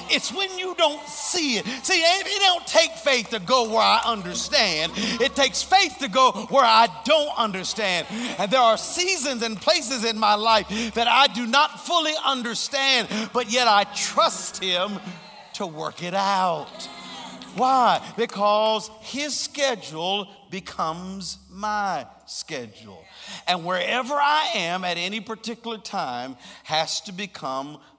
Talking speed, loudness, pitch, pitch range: 145 wpm, -22 LUFS, 230 Hz, 195-275 Hz